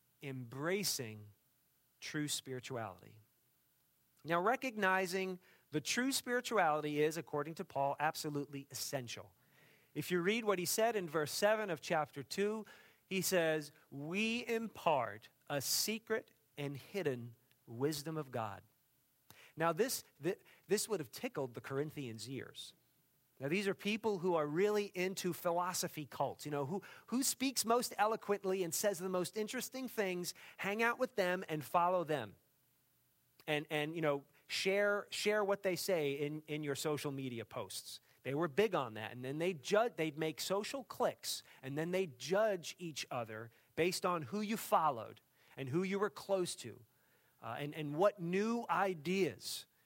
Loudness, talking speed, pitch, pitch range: -38 LUFS, 155 wpm, 160 Hz, 140-195 Hz